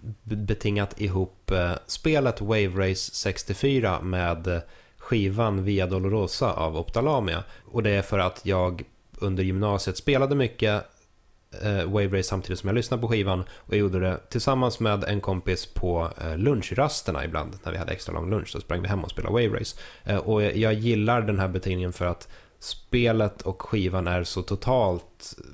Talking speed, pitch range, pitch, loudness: 160 wpm, 90-110 Hz, 100 Hz, -26 LUFS